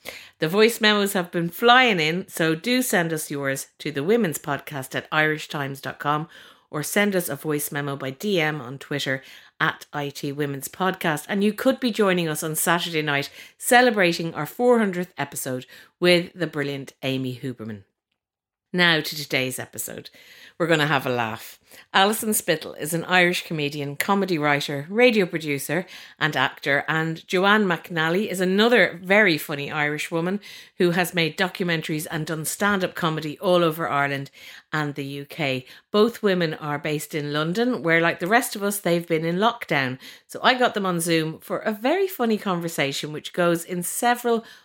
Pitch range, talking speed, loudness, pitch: 145-195 Hz, 170 wpm, -23 LUFS, 165 Hz